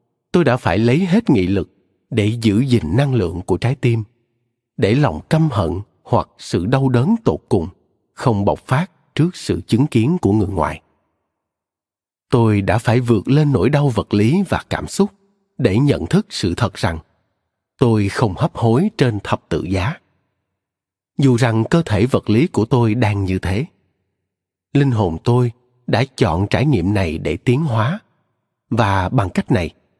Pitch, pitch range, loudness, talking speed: 115 Hz, 95-135 Hz, -17 LUFS, 175 wpm